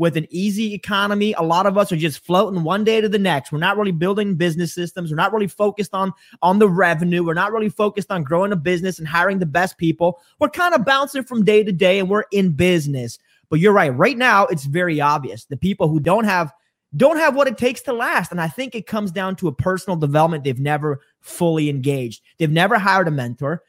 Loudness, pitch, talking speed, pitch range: -18 LUFS, 185 Hz, 240 wpm, 165-205 Hz